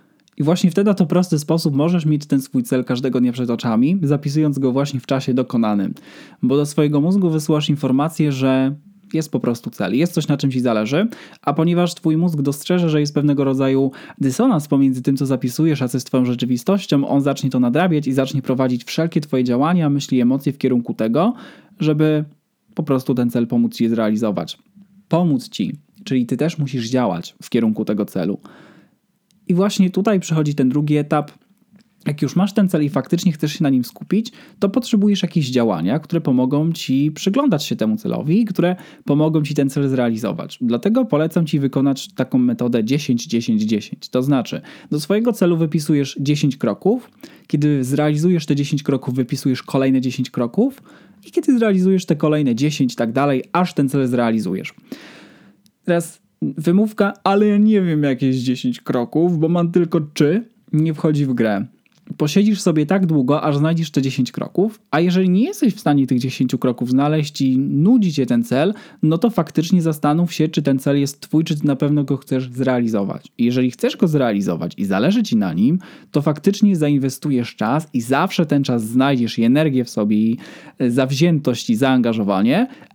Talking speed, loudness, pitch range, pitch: 175 wpm, -18 LUFS, 130-175 Hz, 150 Hz